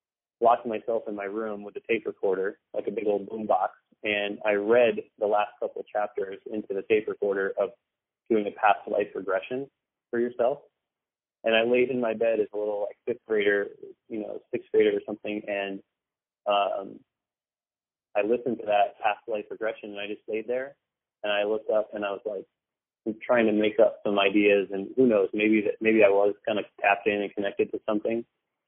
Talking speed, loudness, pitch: 200 wpm, -27 LUFS, 110 Hz